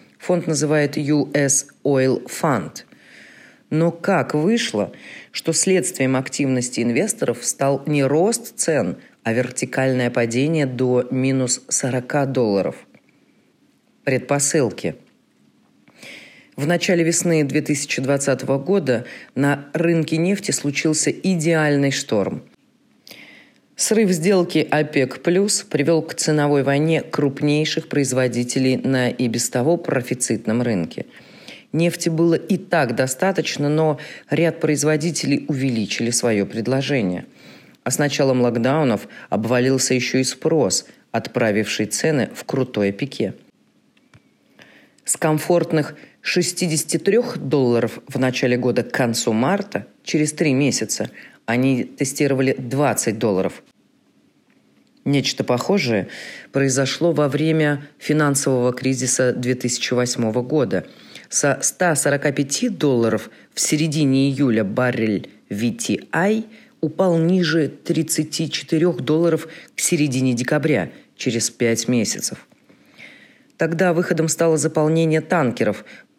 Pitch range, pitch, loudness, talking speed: 130-160 Hz, 145 Hz, -20 LUFS, 100 wpm